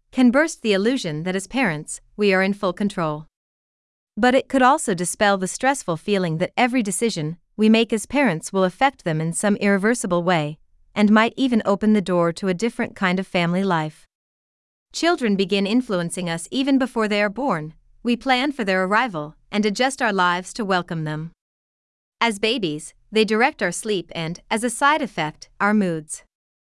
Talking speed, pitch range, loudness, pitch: 180 wpm, 175-235 Hz, -21 LUFS, 205 Hz